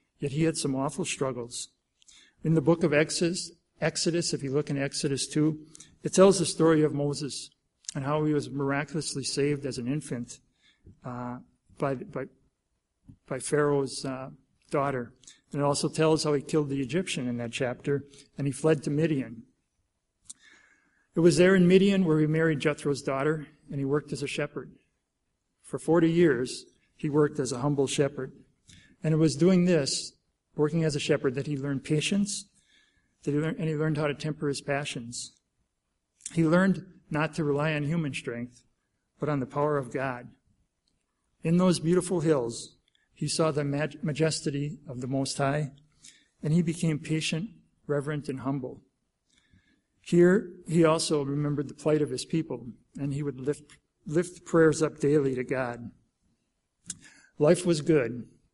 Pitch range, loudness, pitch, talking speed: 140-160 Hz, -28 LUFS, 150 Hz, 165 wpm